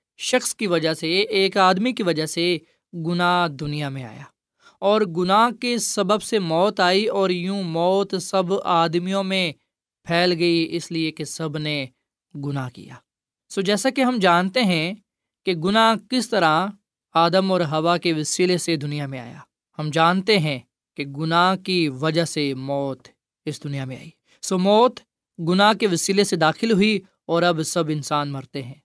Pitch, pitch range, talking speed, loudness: 175 Hz, 155-195 Hz, 170 wpm, -21 LUFS